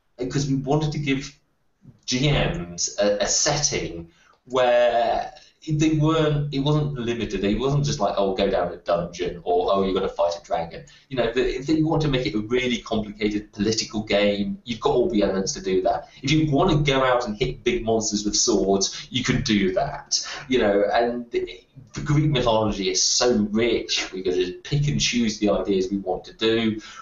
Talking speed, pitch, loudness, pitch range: 200 wpm, 115 Hz, -22 LUFS, 100-140 Hz